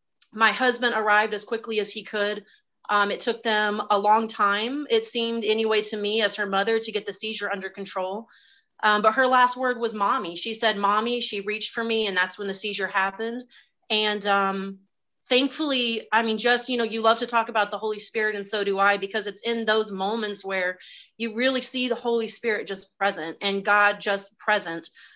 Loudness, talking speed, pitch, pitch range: -24 LUFS, 210 wpm, 215 Hz, 200-230 Hz